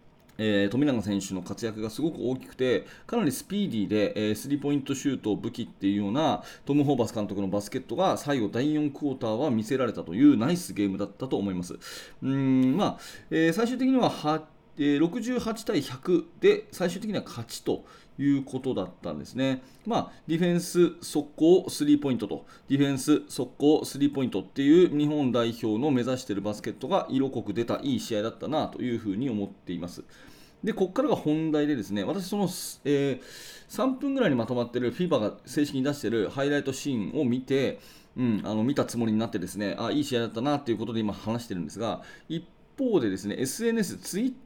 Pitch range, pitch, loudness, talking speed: 110-170 Hz, 135 Hz, -28 LUFS, 420 characters per minute